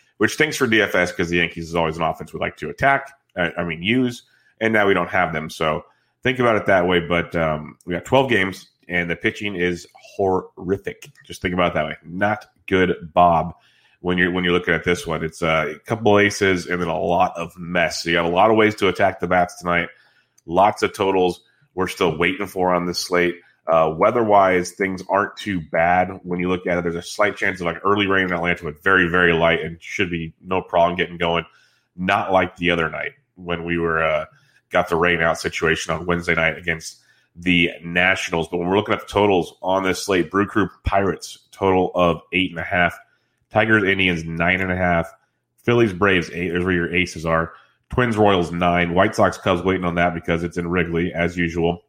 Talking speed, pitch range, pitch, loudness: 220 wpm, 85-95 Hz, 90 Hz, -20 LUFS